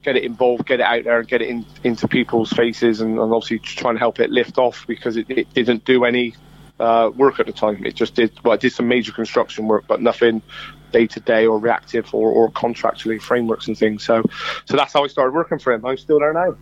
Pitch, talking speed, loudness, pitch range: 115 Hz, 255 wpm, -18 LUFS, 110-125 Hz